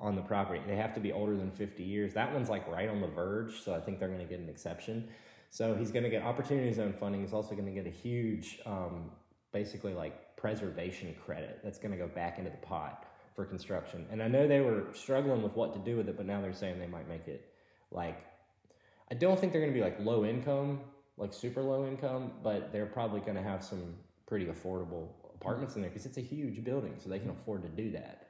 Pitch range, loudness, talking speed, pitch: 95-120 Hz, -37 LUFS, 245 wpm, 105 Hz